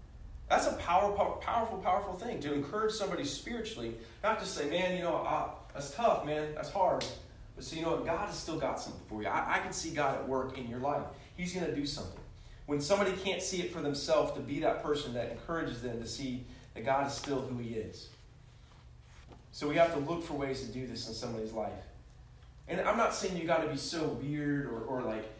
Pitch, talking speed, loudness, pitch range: 140 Hz, 235 wpm, -34 LUFS, 115-165 Hz